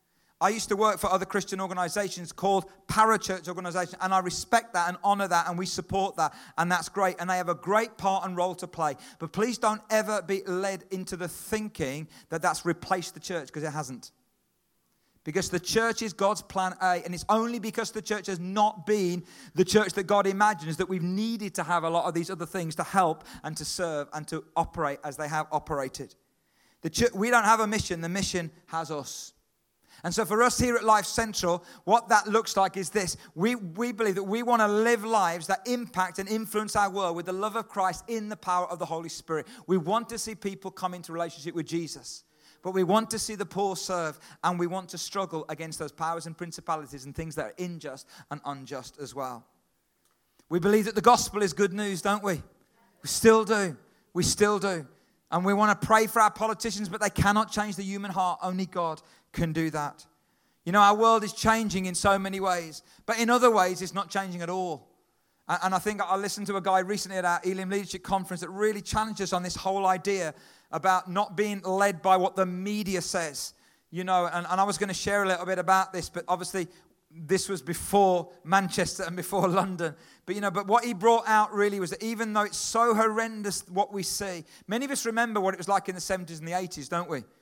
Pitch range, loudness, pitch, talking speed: 175-210 Hz, -28 LUFS, 190 Hz, 225 wpm